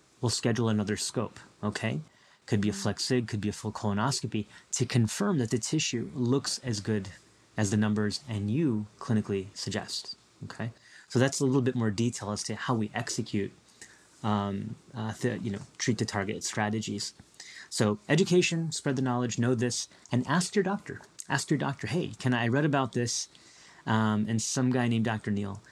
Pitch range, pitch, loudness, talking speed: 105-130 Hz, 115 Hz, -30 LUFS, 180 wpm